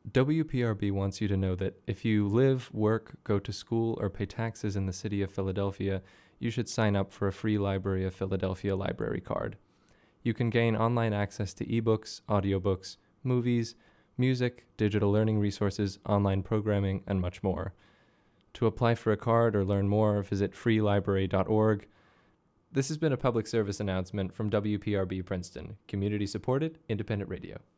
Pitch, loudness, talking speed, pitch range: 105 Hz, -30 LUFS, 160 wpm, 100-115 Hz